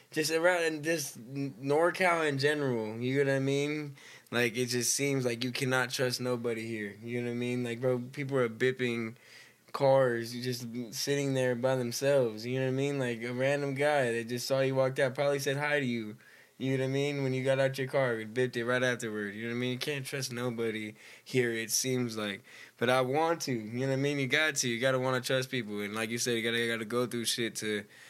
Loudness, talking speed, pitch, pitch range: -31 LUFS, 260 wpm, 125 Hz, 120-140 Hz